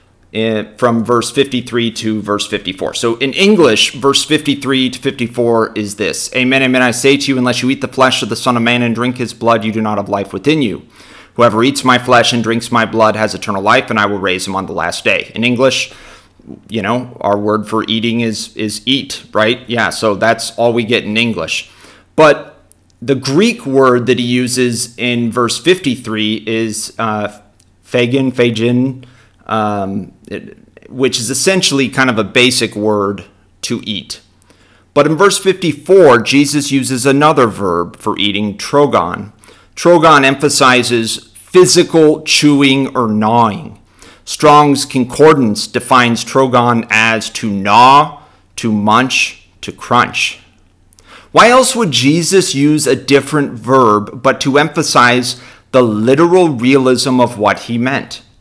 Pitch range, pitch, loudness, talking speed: 110-135 Hz, 120 Hz, -12 LUFS, 160 wpm